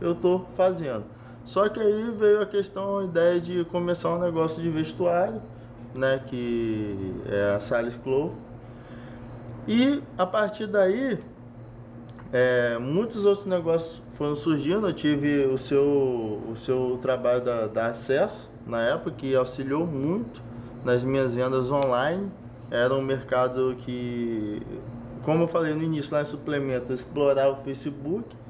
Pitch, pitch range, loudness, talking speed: 135 Hz, 120-170 Hz, -26 LUFS, 135 wpm